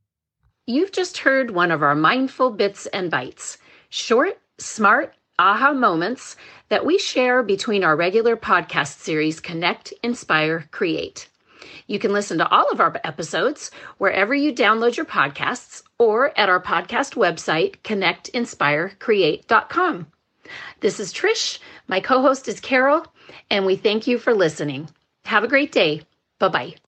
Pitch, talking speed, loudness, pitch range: 220 Hz, 145 wpm, -20 LUFS, 170-270 Hz